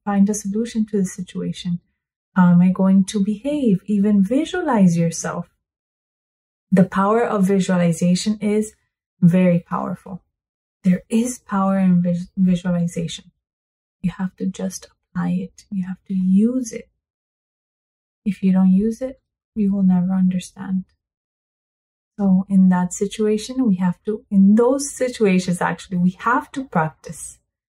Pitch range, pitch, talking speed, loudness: 180-215 Hz, 190 Hz, 135 wpm, -19 LUFS